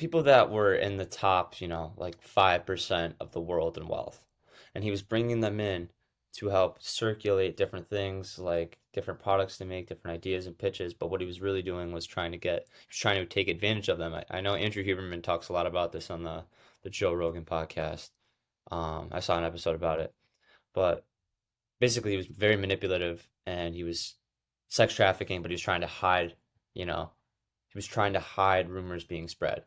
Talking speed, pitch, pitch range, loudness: 210 wpm, 90 Hz, 85-100 Hz, -31 LUFS